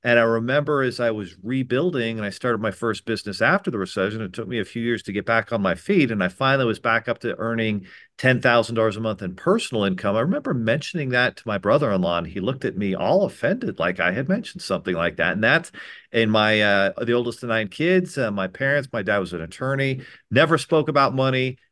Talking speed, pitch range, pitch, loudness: 235 wpm, 110-130 Hz, 115 Hz, -22 LUFS